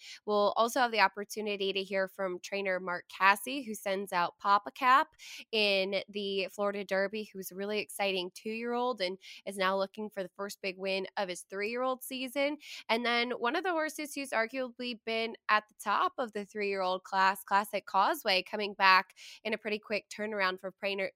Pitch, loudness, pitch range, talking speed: 205 Hz, -32 LUFS, 190-230 Hz, 200 wpm